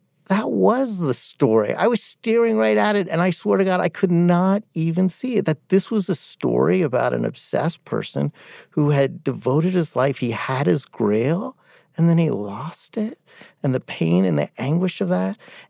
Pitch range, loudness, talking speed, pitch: 135-195 Hz, -21 LUFS, 200 wpm, 170 Hz